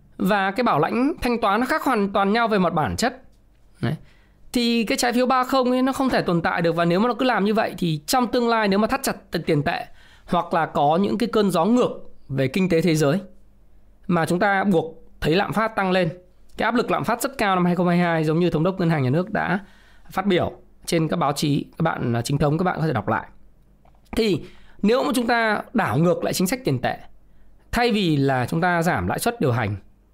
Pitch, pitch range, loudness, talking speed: 180 Hz, 160-230 Hz, -21 LUFS, 245 wpm